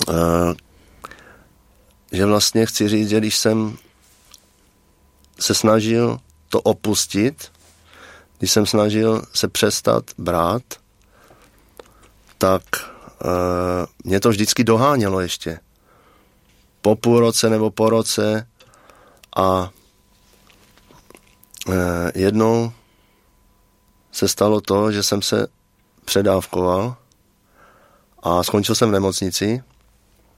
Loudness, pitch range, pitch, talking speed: -19 LUFS, 95-110 Hz, 100 Hz, 90 wpm